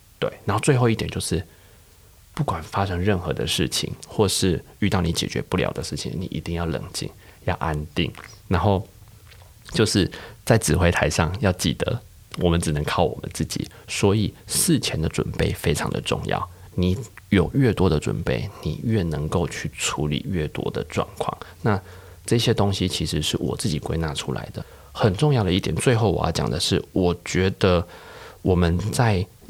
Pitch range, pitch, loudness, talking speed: 85-105 Hz, 95 Hz, -23 LUFS, 255 characters per minute